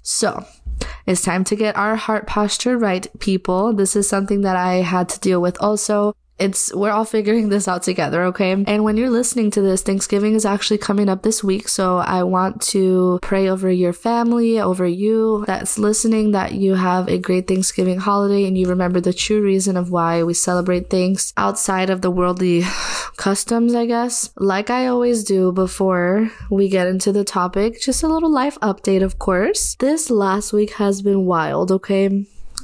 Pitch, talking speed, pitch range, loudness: 195 Hz, 190 wpm, 185-215 Hz, -18 LUFS